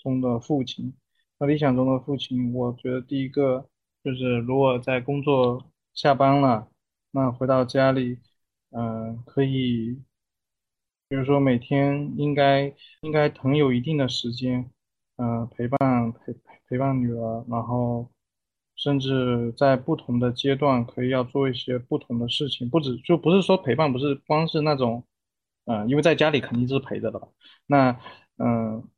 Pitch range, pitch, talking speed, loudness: 120-140 Hz, 130 Hz, 235 characters per minute, -24 LUFS